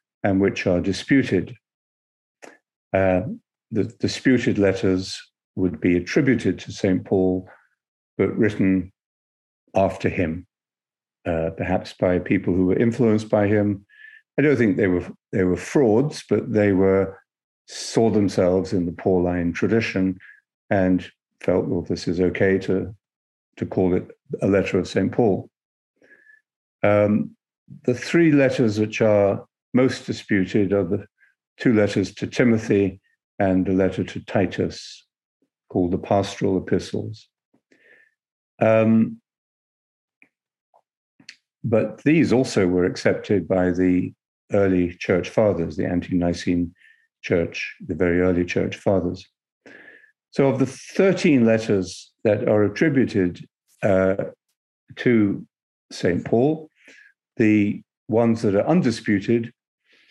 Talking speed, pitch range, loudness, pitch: 120 wpm, 90-115 Hz, -21 LUFS, 100 Hz